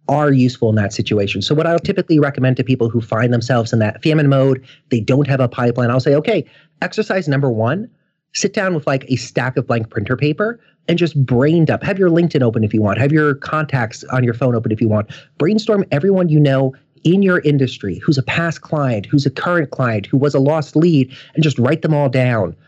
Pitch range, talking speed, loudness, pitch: 125-155 Hz, 230 wpm, -16 LUFS, 140 Hz